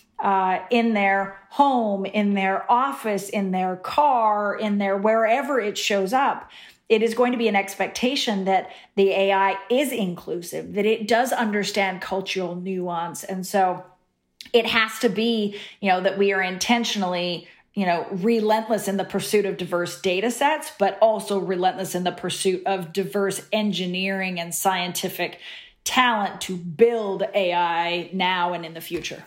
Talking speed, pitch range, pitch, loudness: 155 wpm, 185-220 Hz, 195 Hz, -23 LUFS